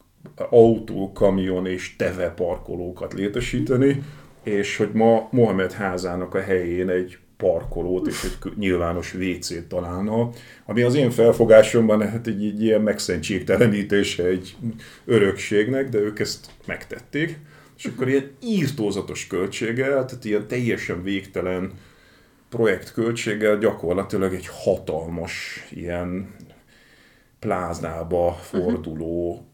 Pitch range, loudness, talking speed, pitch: 90-115 Hz, -22 LUFS, 105 wpm, 100 Hz